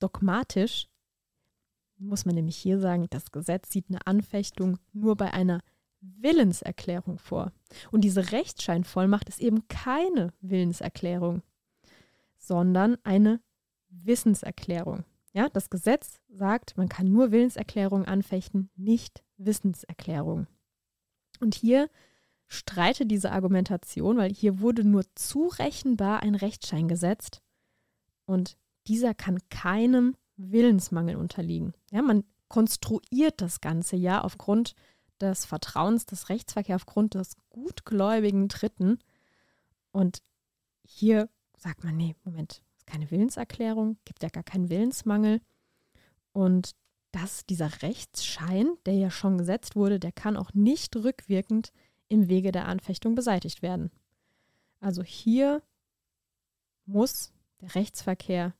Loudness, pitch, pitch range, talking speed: -27 LUFS, 195 Hz, 180-215 Hz, 115 wpm